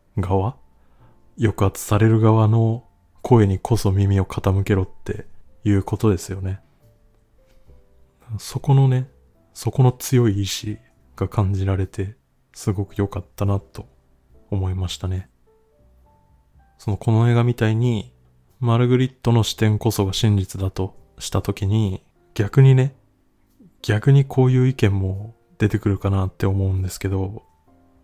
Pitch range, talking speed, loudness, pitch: 95-115 Hz, 250 characters per minute, -20 LUFS, 100 Hz